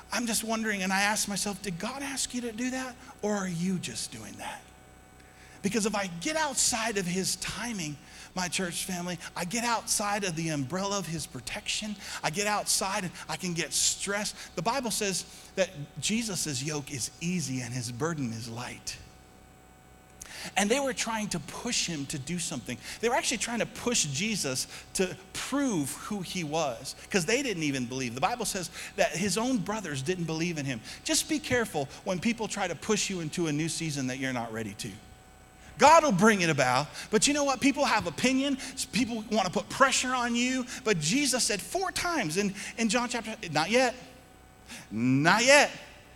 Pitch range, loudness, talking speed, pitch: 155-230 Hz, -29 LUFS, 195 wpm, 195 Hz